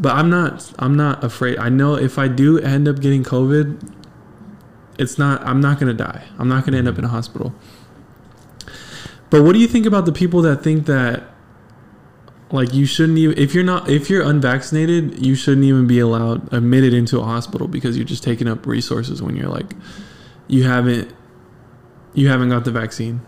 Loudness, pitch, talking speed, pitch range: -16 LUFS, 130 Hz, 200 wpm, 120-145 Hz